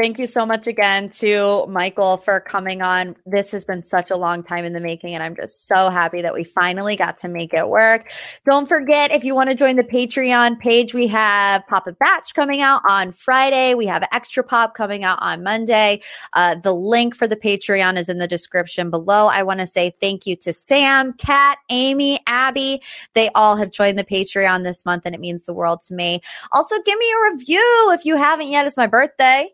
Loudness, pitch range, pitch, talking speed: -17 LUFS, 185-260 Hz, 210 Hz, 220 wpm